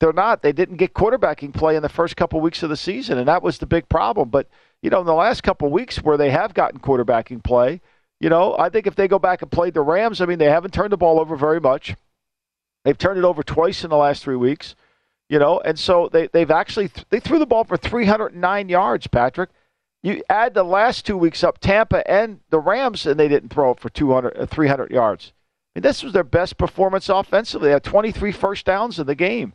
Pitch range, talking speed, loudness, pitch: 150-195 Hz, 240 wpm, -19 LUFS, 175 Hz